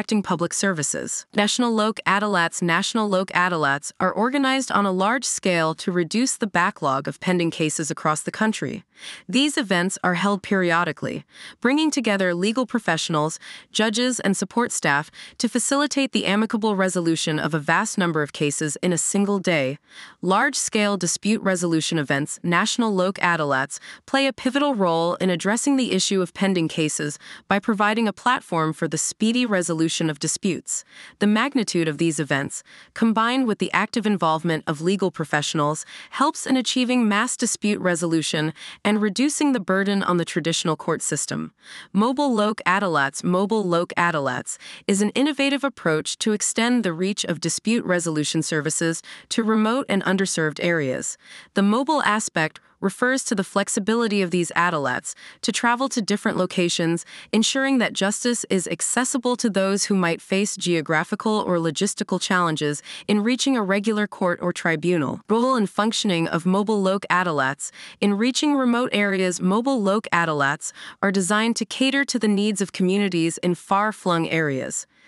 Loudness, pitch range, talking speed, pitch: -22 LUFS, 170-220 Hz, 155 wpm, 195 Hz